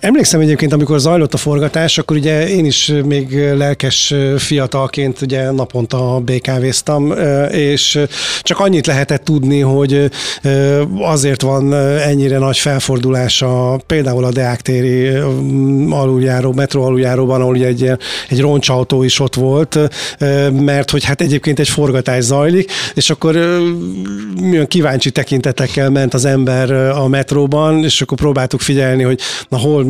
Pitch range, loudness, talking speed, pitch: 130-150 Hz, -13 LUFS, 135 wpm, 140 Hz